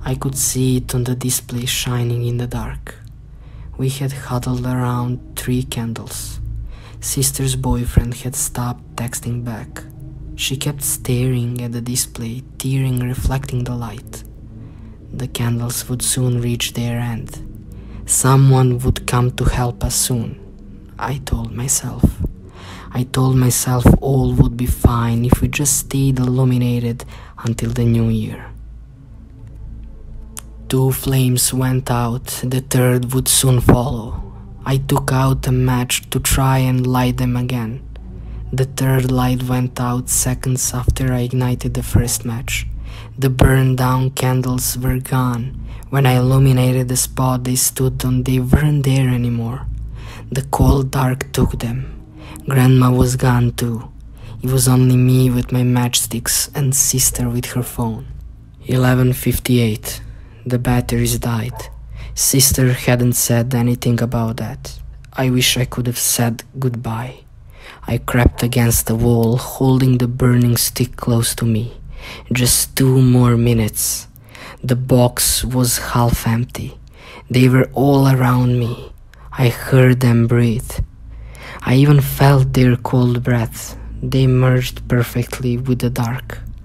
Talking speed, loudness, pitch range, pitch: 135 wpm, -16 LUFS, 120-130 Hz, 125 Hz